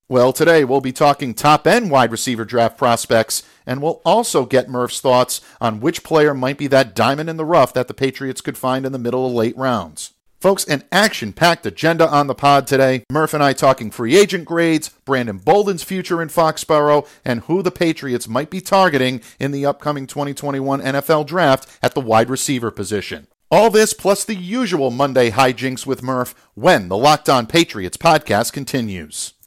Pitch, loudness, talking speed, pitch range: 135 Hz, -17 LUFS, 185 wpm, 125-160 Hz